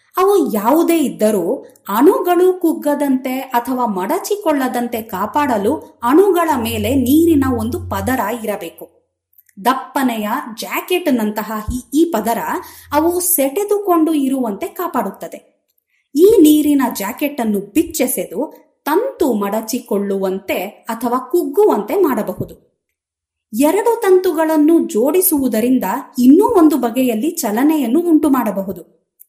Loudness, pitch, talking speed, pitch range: -16 LUFS, 275 Hz, 85 wpm, 230-330 Hz